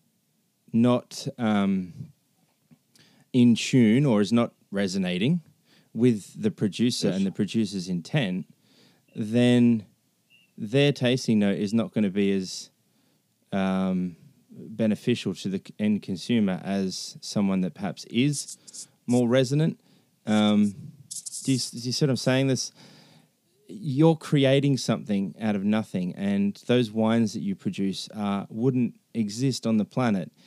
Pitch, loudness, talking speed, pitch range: 120 Hz, -25 LUFS, 130 wpm, 105-140 Hz